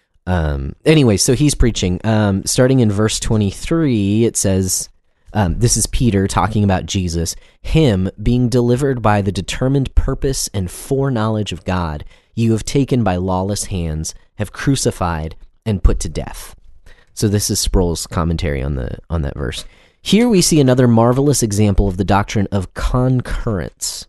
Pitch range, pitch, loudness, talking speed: 90-120 Hz, 100 Hz, -16 LUFS, 155 wpm